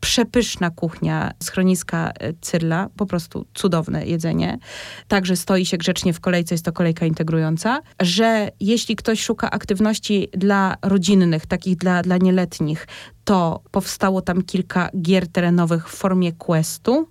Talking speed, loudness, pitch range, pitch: 135 wpm, -20 LUFS, 170-200 Hz, 185 Hz